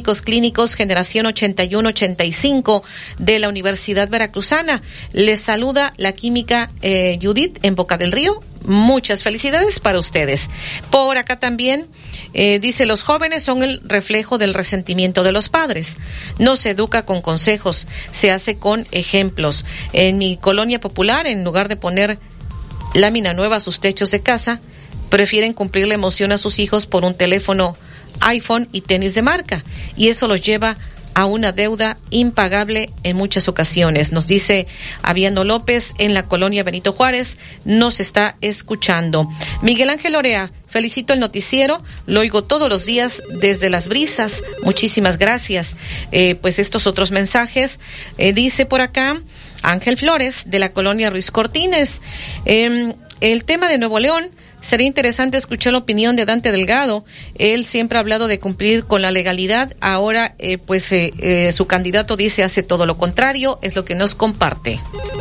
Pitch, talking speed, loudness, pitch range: 210 Hz, 155 wpm, -15 LUFS, 190-240 Hz